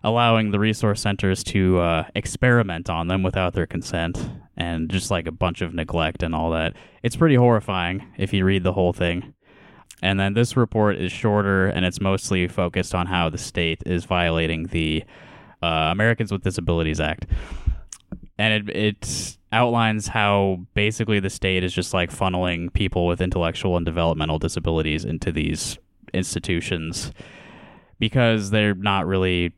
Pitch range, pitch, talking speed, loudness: 85-105 Hz, 95 Hz, 160 wpm, -22 LUFS